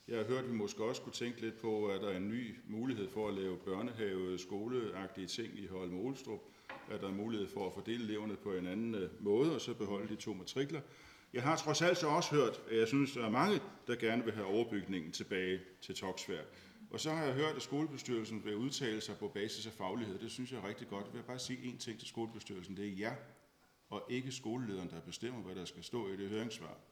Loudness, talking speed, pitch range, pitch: -40 LUFS, 245 wpm, 100-125 Hz, 110 Hz